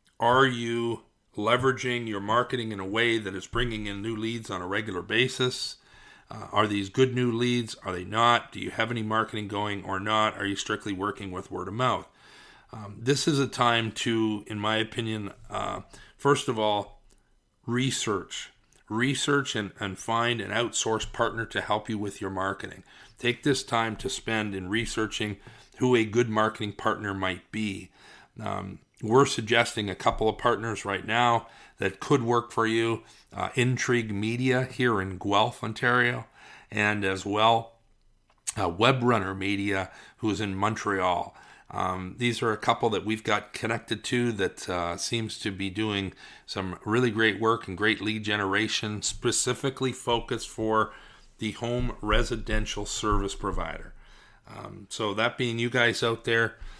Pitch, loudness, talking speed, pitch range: 110 Hz, -27 LUFS, 165 wpm, 105-120 Hz